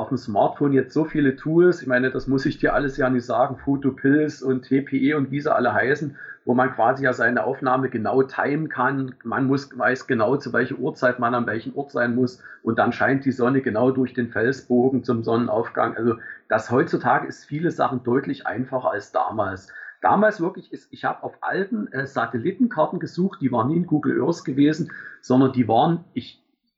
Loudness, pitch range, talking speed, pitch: -22 LUFS, 125-150 Hz, 200 wpm, 135 Hz